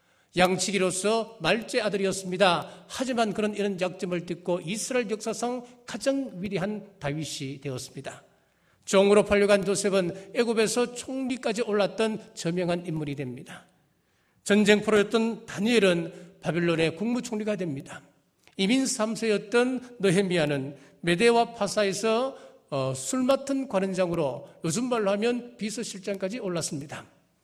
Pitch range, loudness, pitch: 180-230 Hz, -26 LUFS, 200 Hz